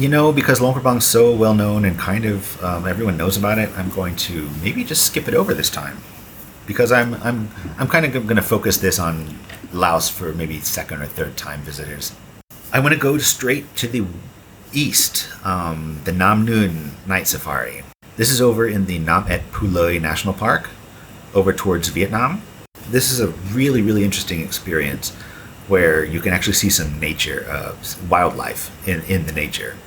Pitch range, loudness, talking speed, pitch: 85-115 Hz, -18 LUFS, 185 wpm, 100 Hz